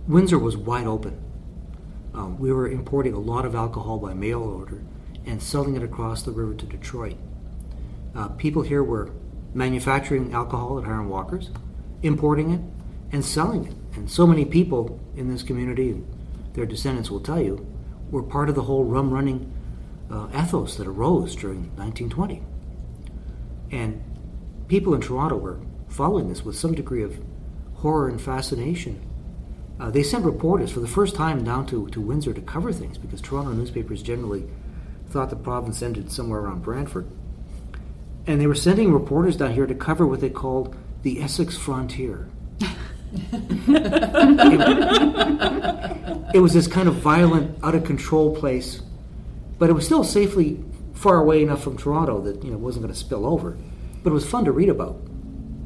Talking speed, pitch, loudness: 165 wpm, 125 Hz, -22 LUFS